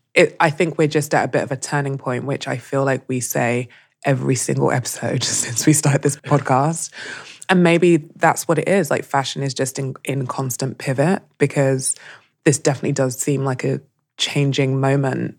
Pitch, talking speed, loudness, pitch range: 135 Hz, 190 wpm, -19 LUFS, 130-145 Hz